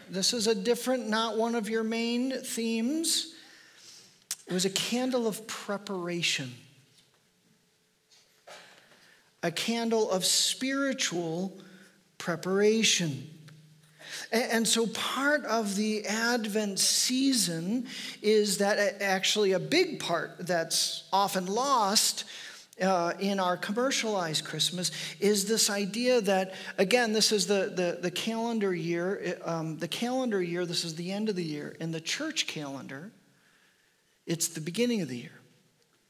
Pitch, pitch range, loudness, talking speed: 200 Hz, 175-230 Hz, -28 LUFS, 125 wpm